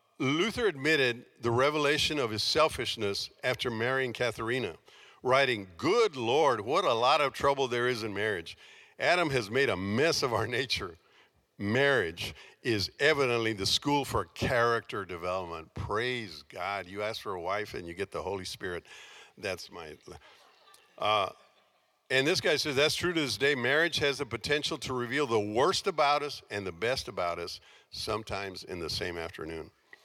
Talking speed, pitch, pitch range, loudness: 165 wpm, 125 Hz, 110-145 Hz, -30 LUFS